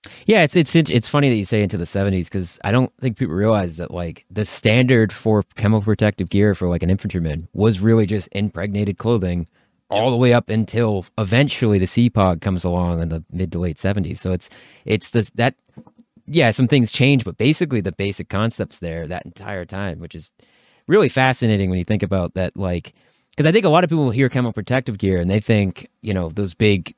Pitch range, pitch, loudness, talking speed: 95-120 Hz, 105 Hz, -19 LUFS, 215 wpm